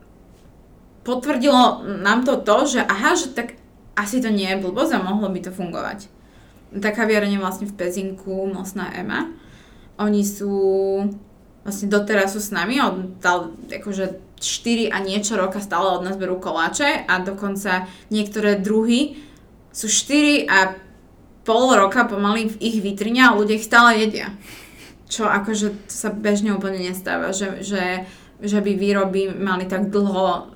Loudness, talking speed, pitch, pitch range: -20 LUFS, 150 wpm, 205 Hz, 190-220 Hz